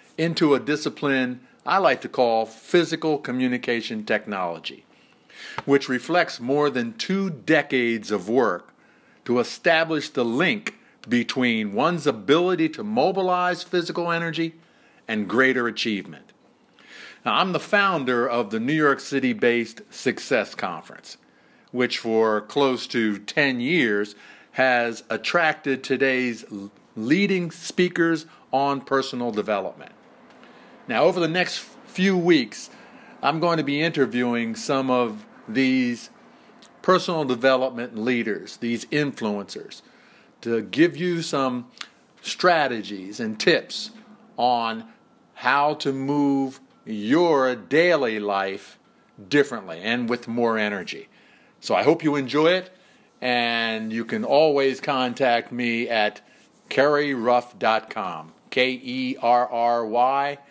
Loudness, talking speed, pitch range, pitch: -23 LUFS, 115 wpm, 120-160 Hz, 130 Hz